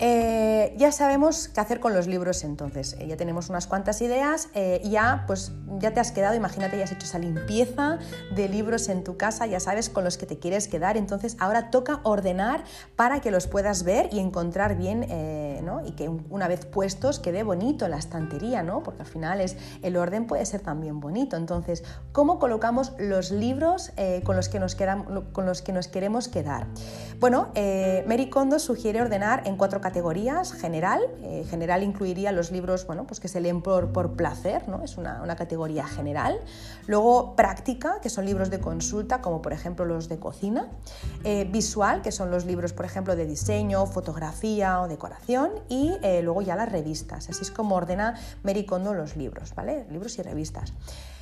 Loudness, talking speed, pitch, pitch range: -27 LUFS, 195 wpm, 190 Hz, 170-220 Hz